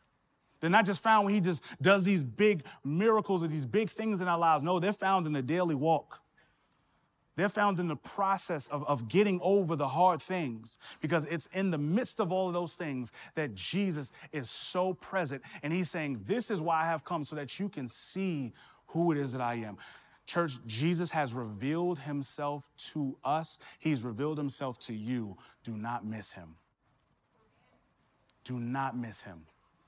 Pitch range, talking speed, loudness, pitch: 130-185 Hz, 185 wpm, -32 LUFS, 155 Hz